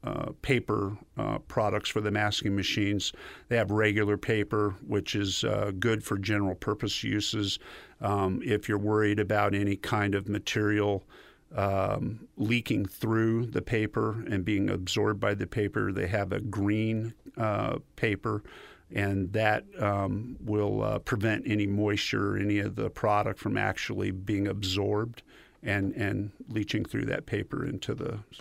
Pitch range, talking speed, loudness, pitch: 100-110 Hz, 150 wpm, -30 LUFS, 105 Hz